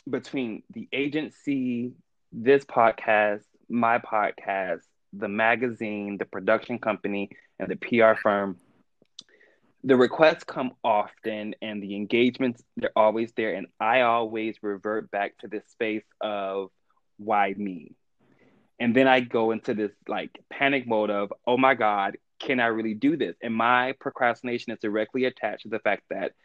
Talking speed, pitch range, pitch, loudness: 145 wpm, 105-125 Hz, 115 Hz, -26 LUFS